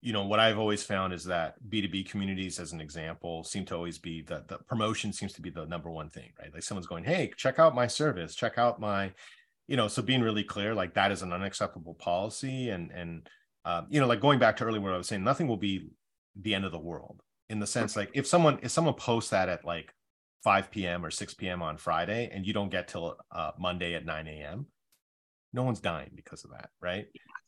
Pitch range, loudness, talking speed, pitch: 85-115 Hz, -31 LUFS, 240 wpm, 100 Hz